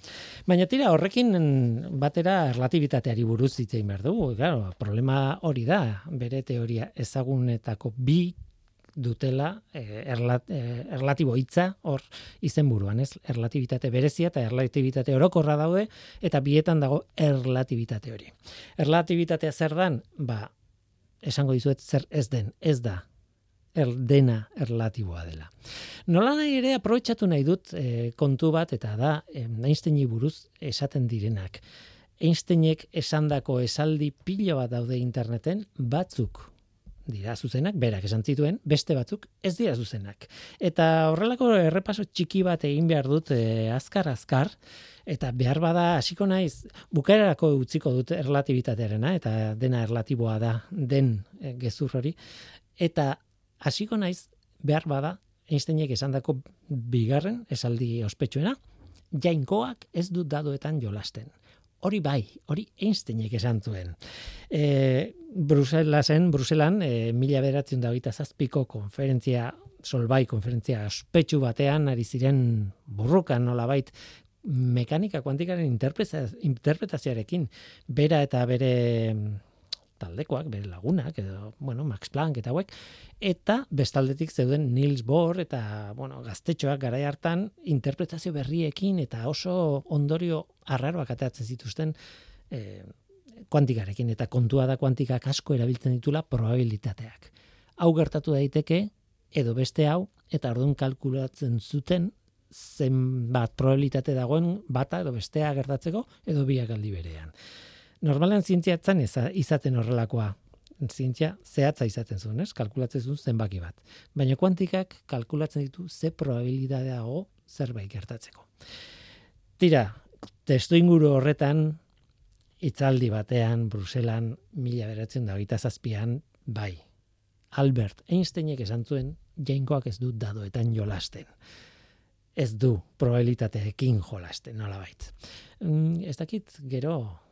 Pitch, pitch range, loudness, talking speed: 135 Hz, 120-155 Hz, -27 LUFS, 115 wpm